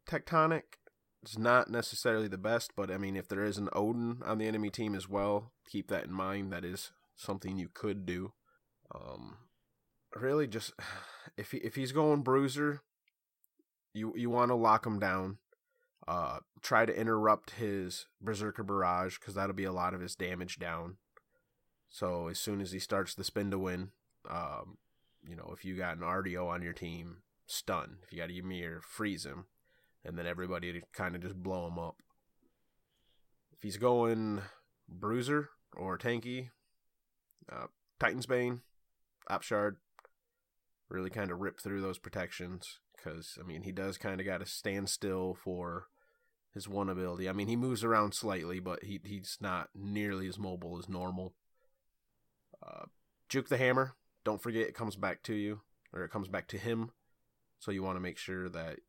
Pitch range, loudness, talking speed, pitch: 90-115 Hz, -36 LUFS, 175 wpm, 100 Hz